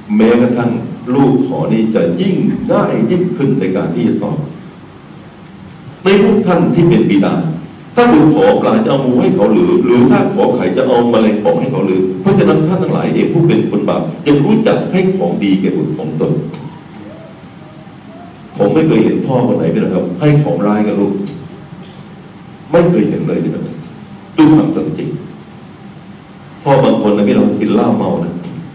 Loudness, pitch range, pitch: -12 LUFS, 120-185 Hz, 160 Hz